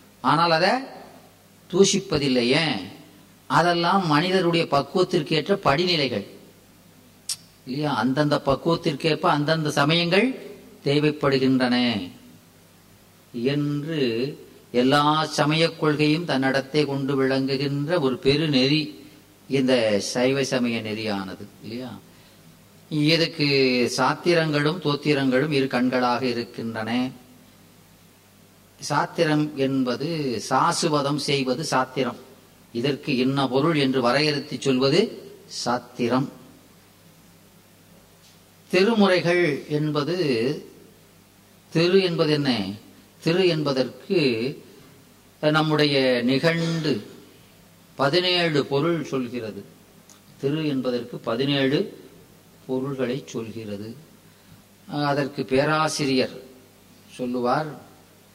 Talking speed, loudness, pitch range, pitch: 65 wpm, -22 LUFS, 125-155 Hz, 135 Hz